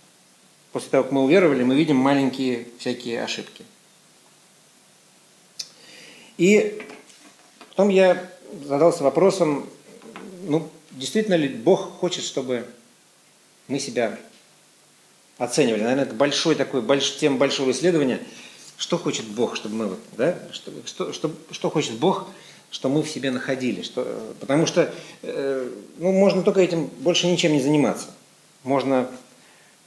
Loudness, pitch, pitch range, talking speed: -22 LUFS, 155 Hz, 135-185 Hz, 120 wpm